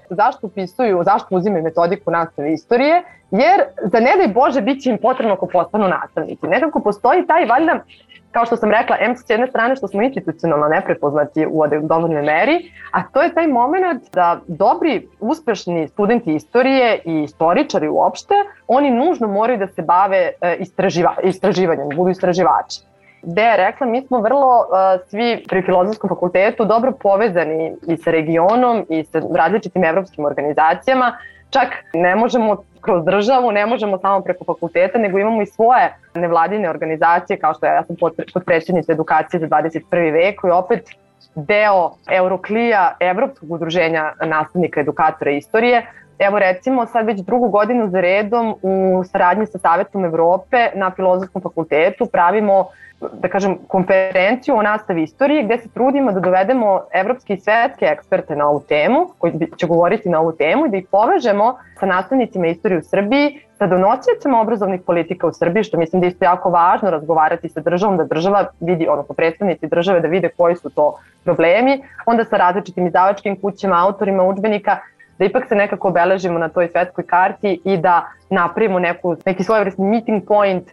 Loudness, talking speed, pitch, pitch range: -16 LUFS, 165 wpm, 190 Hz, 170-225 Hz